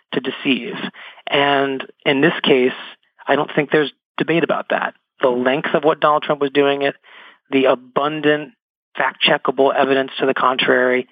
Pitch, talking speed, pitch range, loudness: 140 Hz, 160 wpm, 135-150 Hz, -17 LUFS